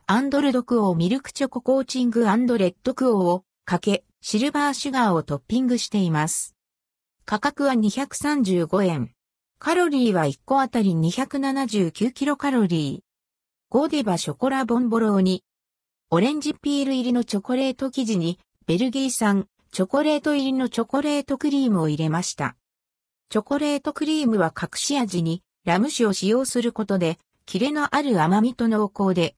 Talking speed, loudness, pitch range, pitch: 345 characters per minute, -23 LUFS, 180-270 Hz, 230 Hz